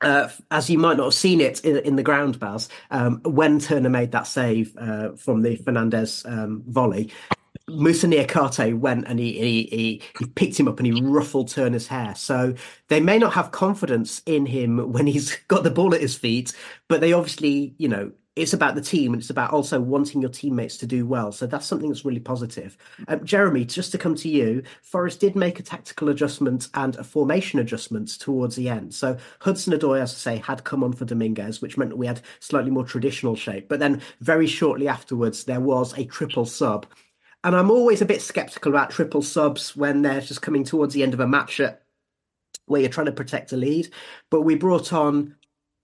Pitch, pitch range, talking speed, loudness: 140 Hz, 120-155 Hz, 210 wpm, -22 LUFS